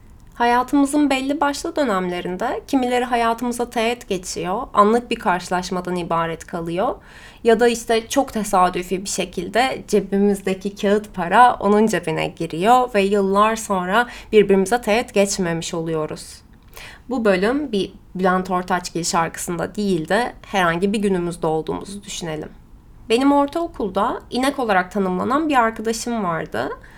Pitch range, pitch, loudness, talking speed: 180-240 Hz, 205 Hz, -20 LUFS, 120 wpm